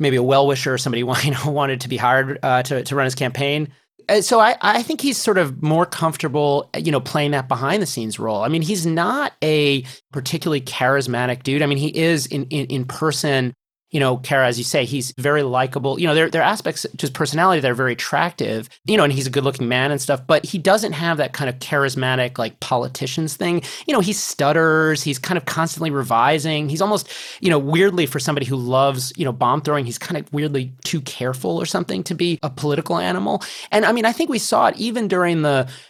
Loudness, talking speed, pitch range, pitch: -19 LUFS, 235 wpm, 130-165 Hz, 145 Hz